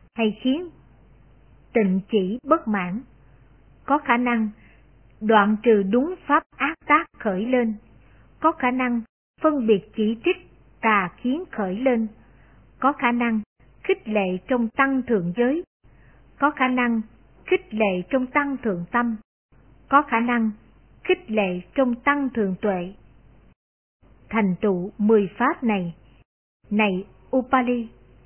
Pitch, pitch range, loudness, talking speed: 230 Hz, 205-265 Hz, -23 LUFS, 130 wpm